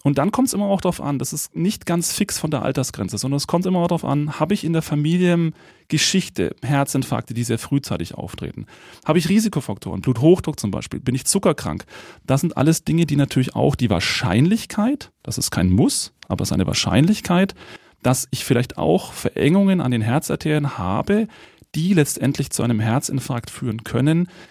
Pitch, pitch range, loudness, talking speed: 150 Hz, 125-175 Hz, -20 LUFS, 190 wpm